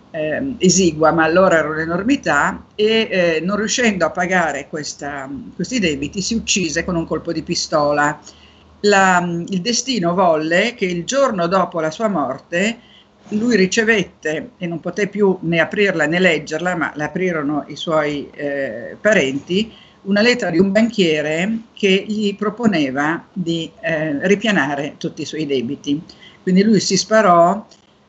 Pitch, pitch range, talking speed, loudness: 180 Hz, 155-205 Hz, 145 wpm, -17 LUFS